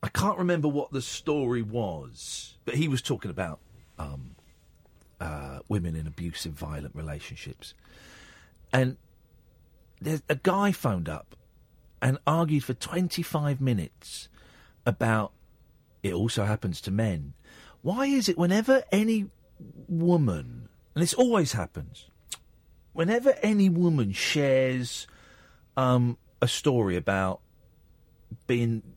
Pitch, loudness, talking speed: 120 Hz, -27 LUFS, 115 wpm